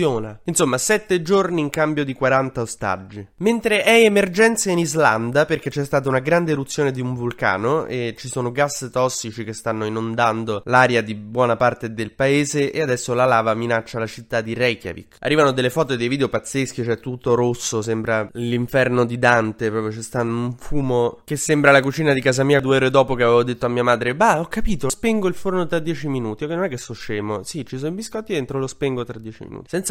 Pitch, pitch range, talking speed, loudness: 130 Hz, 115-150 Hz, 215 wpm, -20 LUFS